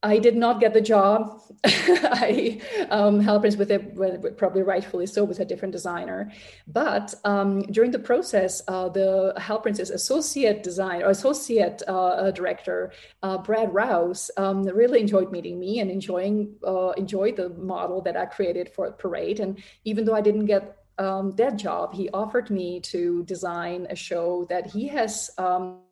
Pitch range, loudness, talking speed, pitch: 185-215 Hz, -24 LUFS, 170 wpm, 195 Hz